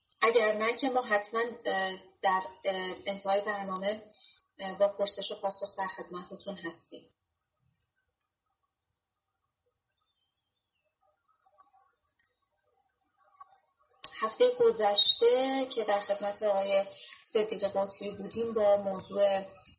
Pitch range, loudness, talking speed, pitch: 195-260 Hz, -30 LUFS, 80 wpm, 205 Hz